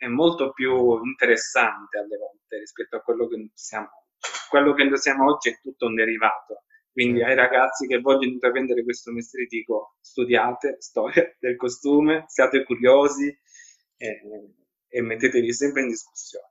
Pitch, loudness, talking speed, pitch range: 130 Hz, -22 LUFS, 155 wpm, 120-170 Hz